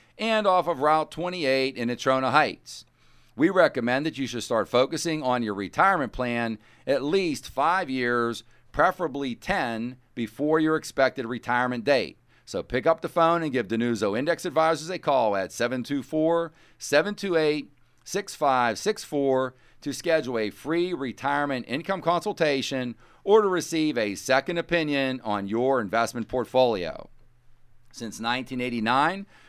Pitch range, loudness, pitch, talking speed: 120-160 Hz, -25 LUFS, 130 Hz, 130 wpm